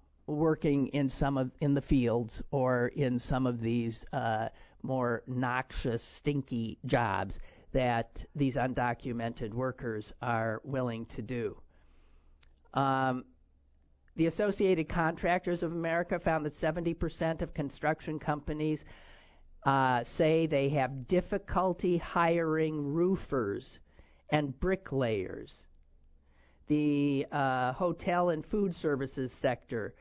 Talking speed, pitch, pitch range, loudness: 105 wpm, 135 Hz, 115-160 Hz, -32 LUFS